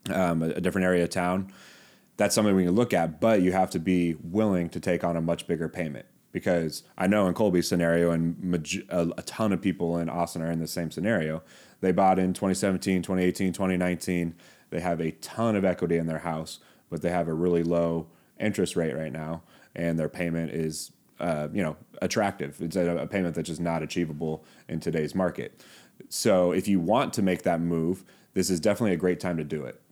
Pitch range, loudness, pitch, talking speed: 80-90 Hz, -27 LUFS, 85 Hz, 215 wpm